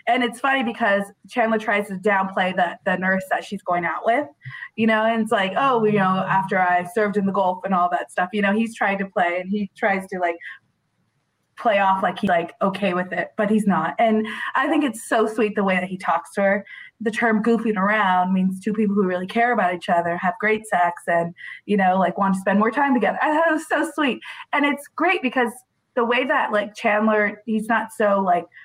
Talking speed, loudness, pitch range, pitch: 240 wpm, -21 LUFS, 185-230 Hz, 205 Hz